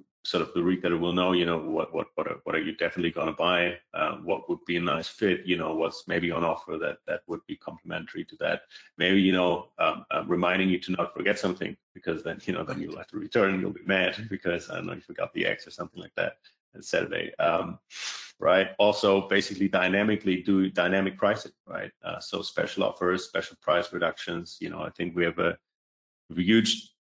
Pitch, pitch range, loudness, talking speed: 90 Hz, 85-95 Hz, -28 LUFS, 220 wpm